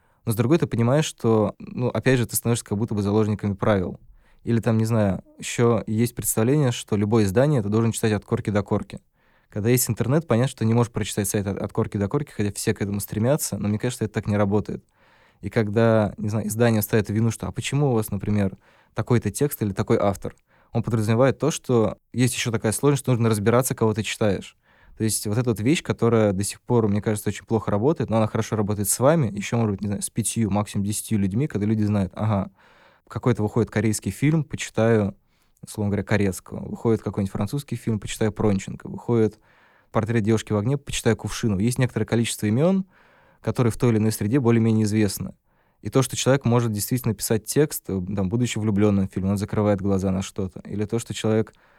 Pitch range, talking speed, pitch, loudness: 105-120 Hz, 210 wpm, 110 Hz, -23 LUFS